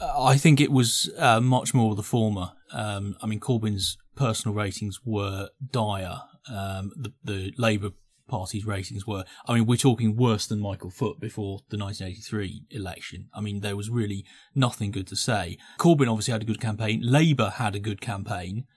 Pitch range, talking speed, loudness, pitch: 100-125 Hz, 180 wpm, -26 LUFS, 110 Hz